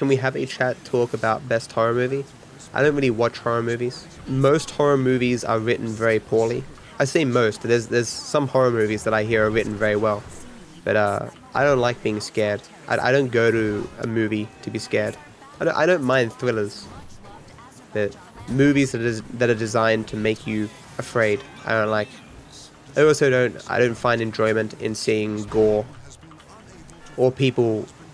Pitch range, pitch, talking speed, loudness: 110-130 Hz, 115 Hz, 190 wpm, -22 LUFS